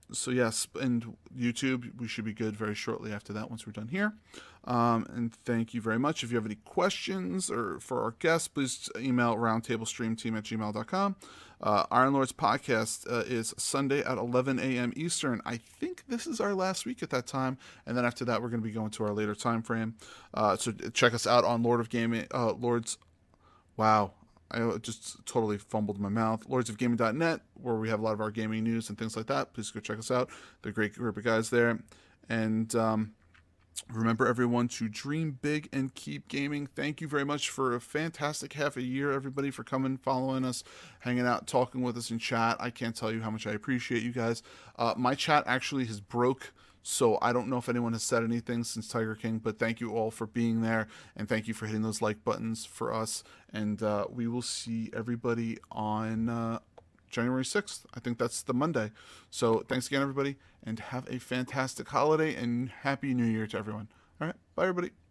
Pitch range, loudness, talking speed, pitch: 110-130 Hz, -32 LUFS, 210 wpm, 120 Hz